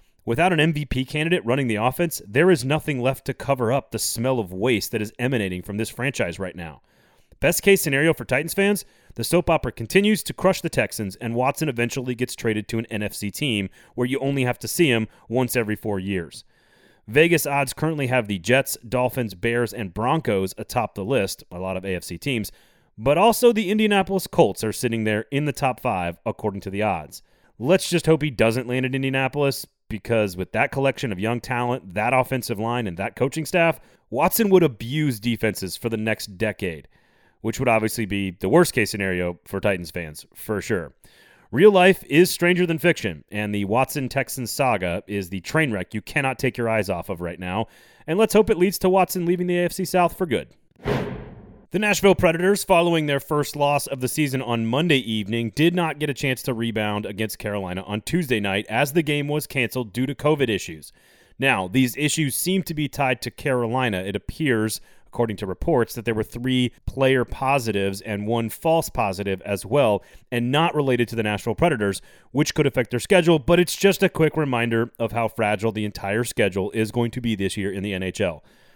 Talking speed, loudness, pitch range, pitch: 205 wpm, -22 LUFS, 105-150 Hz, 125 Hz